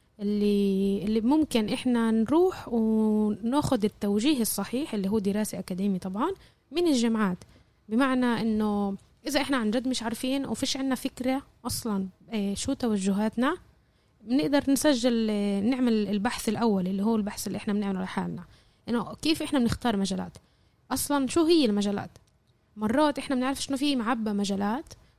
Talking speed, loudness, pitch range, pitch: 140 wpm, -27 LUFS, 205-270 Hz, 225 Hz